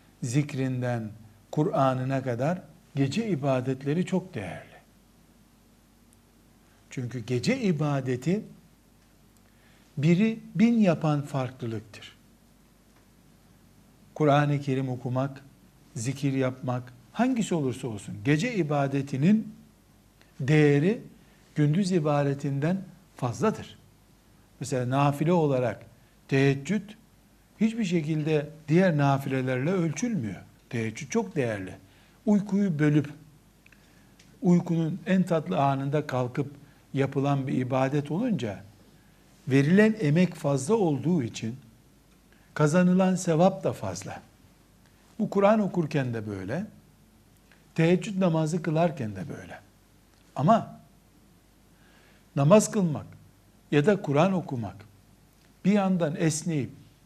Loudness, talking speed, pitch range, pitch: -26 LUFS, 85 wpm, 130-180 Hz, 145 Hz